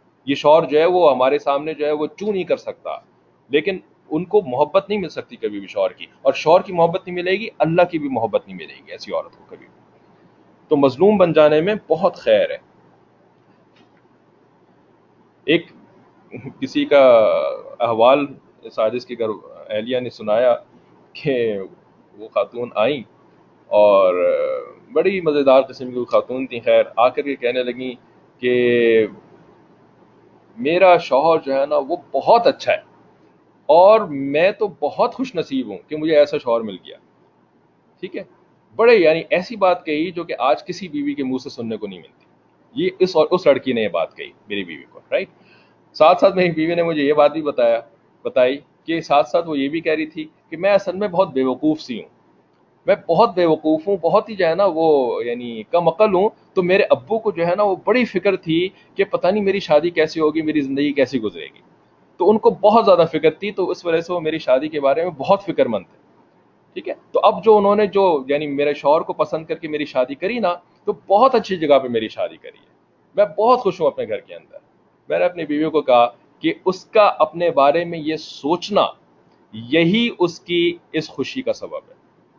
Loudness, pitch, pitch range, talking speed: -18 LUFS, 165 Hz, 145-205 Hz, 205 wpm